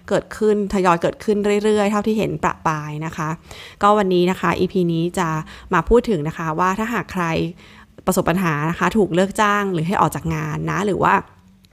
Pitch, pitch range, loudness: 180 Hz, 160-205 Hz, -19 LUFS